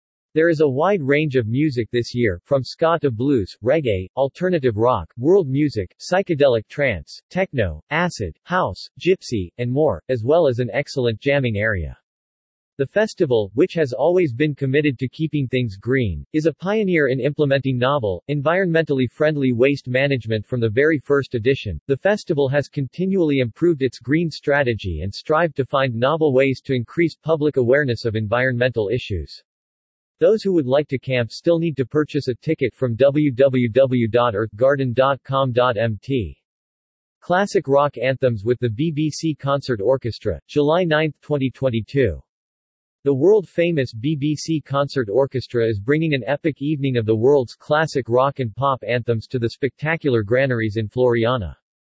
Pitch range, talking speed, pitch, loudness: 120-150 Hz, 150 wpm, 135 Hz, -20 LUFS